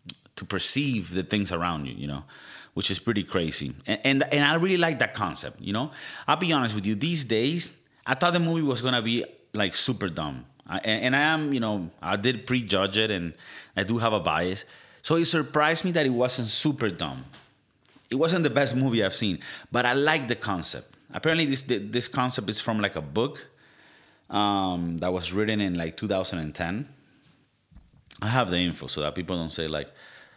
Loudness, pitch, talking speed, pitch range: -26 LUFS, 110 Hz, 205 wpm, 90-135 Hz